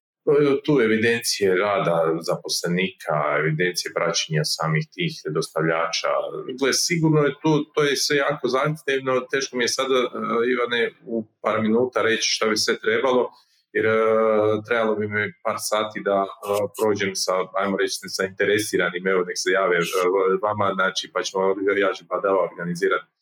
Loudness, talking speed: -22 LUFS, 145 wpm